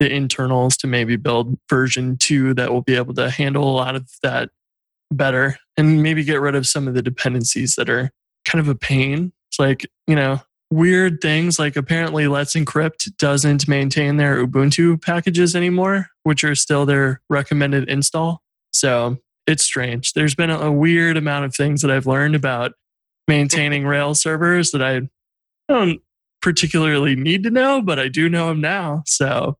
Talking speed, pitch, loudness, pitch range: 175 wpm, 145 Hz, -18 LUFS, 130-160 Hz